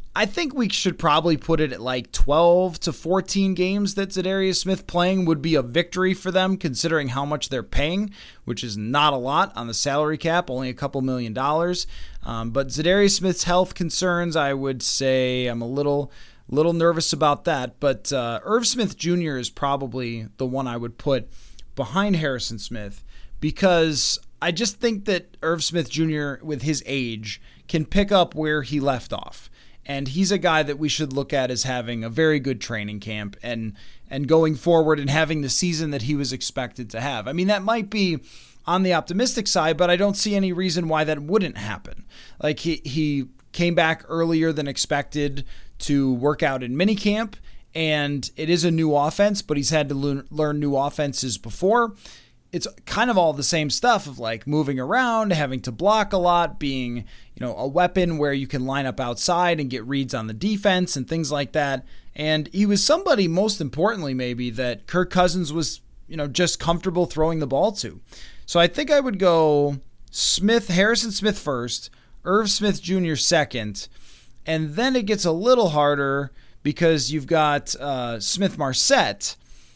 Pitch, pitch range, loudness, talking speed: 155 Hz, 135-180 Hz, -22 LUFS, 190 wpm